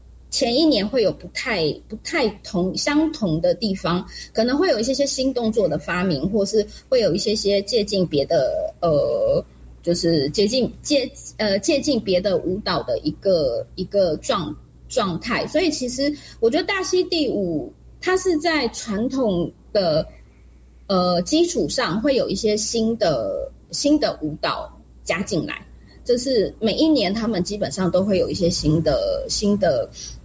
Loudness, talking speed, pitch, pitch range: -21 LUFS, 225 characters per minute, 215 Hz, 180-295 Hz